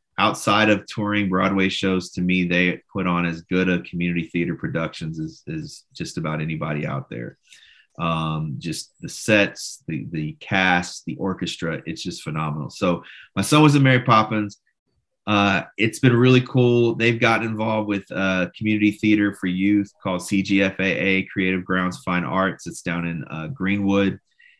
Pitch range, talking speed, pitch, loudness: 90-110 Hz, 165 wpm, 95 Hz, -21 LUFS